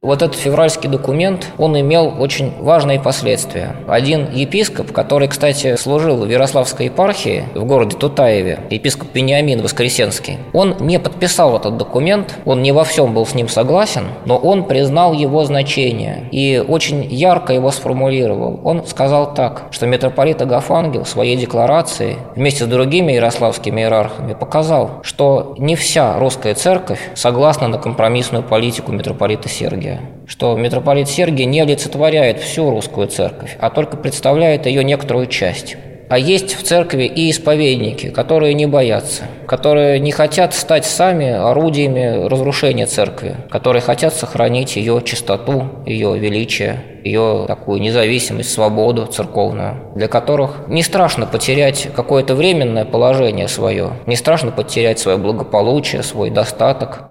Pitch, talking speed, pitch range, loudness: 135 Hz, 140 wpm, 120-155 Hz, -14 LUFS